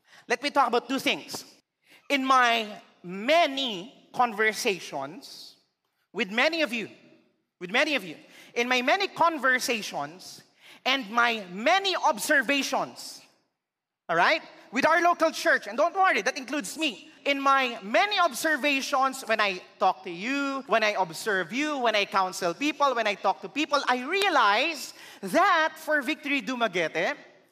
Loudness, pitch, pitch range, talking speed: -25 LUFS, 270 Hz, 225-305 Hz, 145 wpm